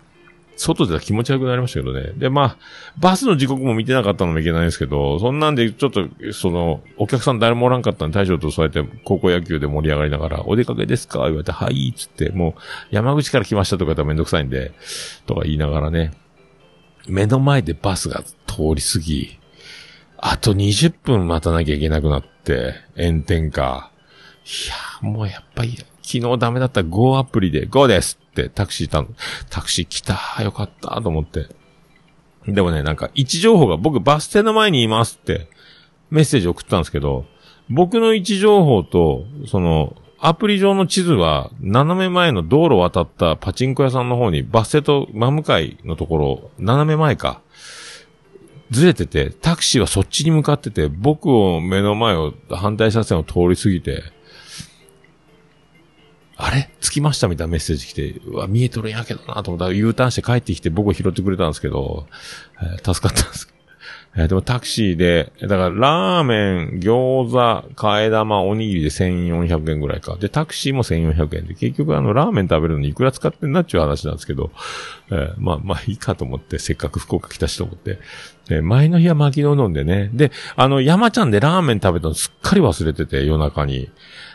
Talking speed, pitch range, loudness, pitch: 380 characters per minute, 85-135 Hz, -18 LUFS, 105 Hz